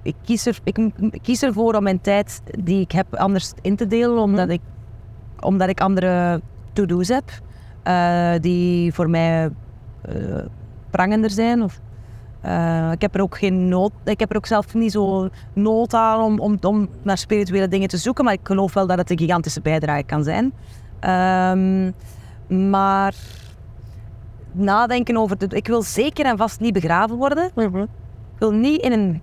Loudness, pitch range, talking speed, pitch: -19 LUFS, 160-215 Hz, 170 wpm, 190 Hz